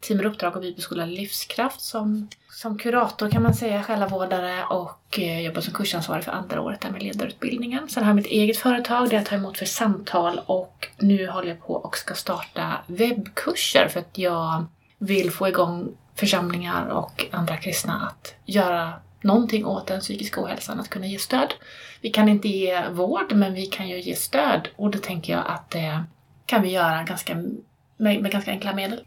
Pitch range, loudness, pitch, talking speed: 180-215 Hz, -24 LUFS, 200 Hz, 190 wpm